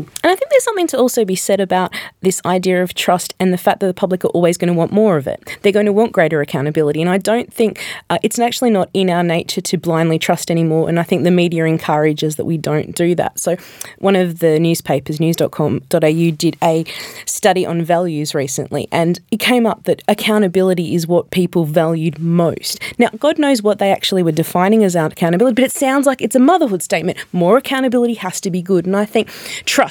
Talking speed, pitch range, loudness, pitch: 225 wpm, 165-210 Hz, -15 LUFS, 180 Hz